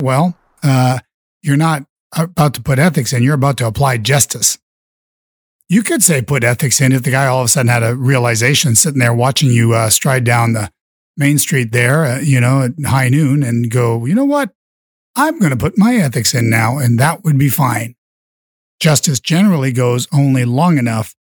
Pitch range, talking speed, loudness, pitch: 120-150 Hz, 200 wpm, -13 LUFS, 135 Hz